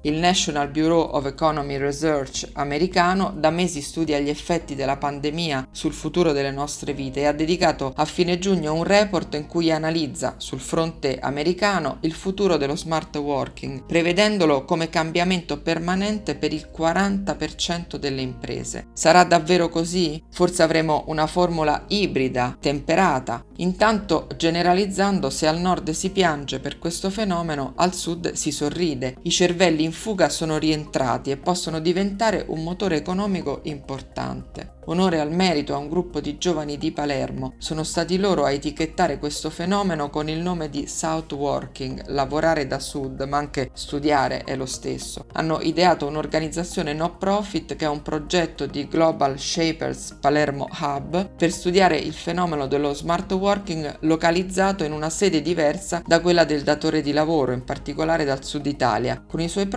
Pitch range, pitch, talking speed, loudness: 145-175 Hz, 160 Hz, 155 wpm, -22 LUFS